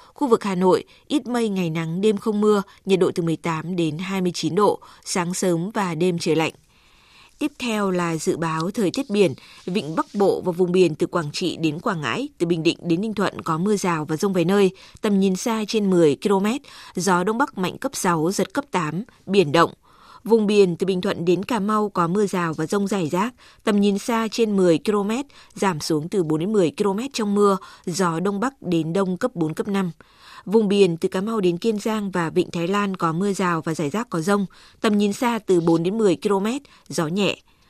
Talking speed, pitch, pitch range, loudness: 230 wpm, 190 Hz, 175-210 Hz, -22 LUFS